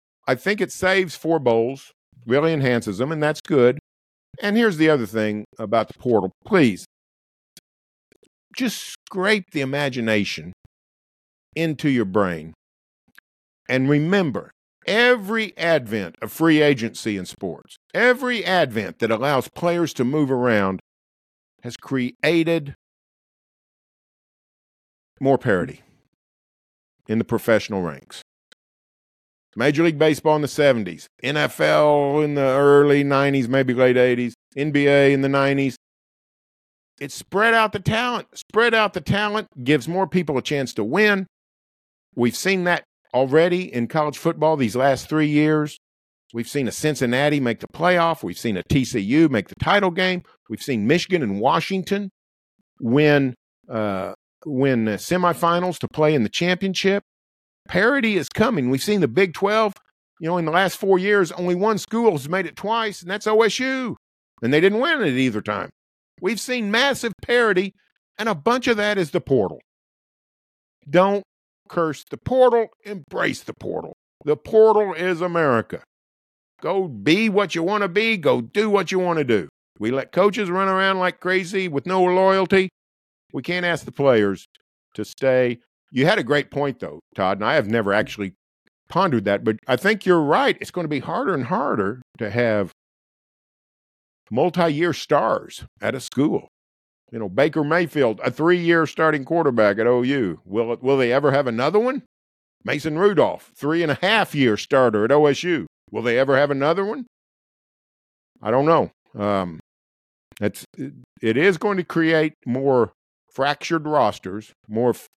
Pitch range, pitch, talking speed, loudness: 125-190 Hz, 155 Hz, 155 wpm, -20 LUFS